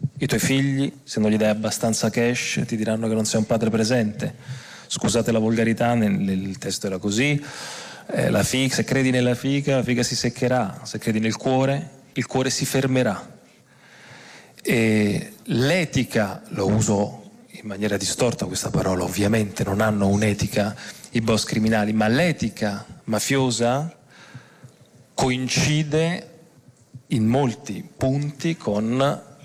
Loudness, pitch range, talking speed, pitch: -22 LUFS, 110-135 Hz, 135 wpm, 120 Hz